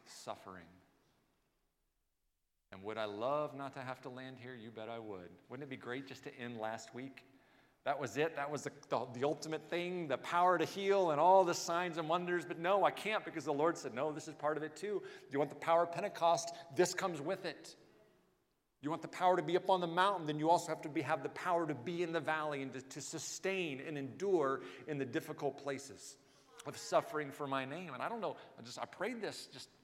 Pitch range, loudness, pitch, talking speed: 135-170 Hz, -37 LUFS, 155 Hz, 235 wpm